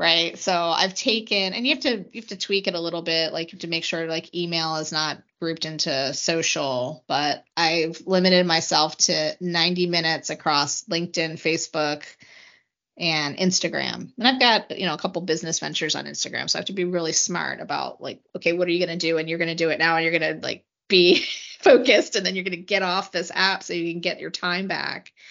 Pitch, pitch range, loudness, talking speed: 170 Hz, 160-190 Hz, -22 LUFS, 230 wpm